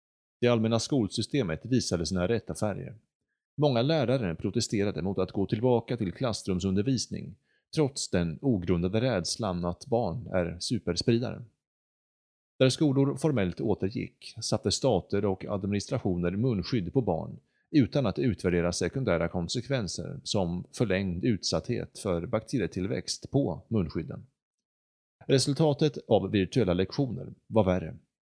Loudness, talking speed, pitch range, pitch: -29 LUFS, 110 wpm, 90-125 Hz, 100 Hz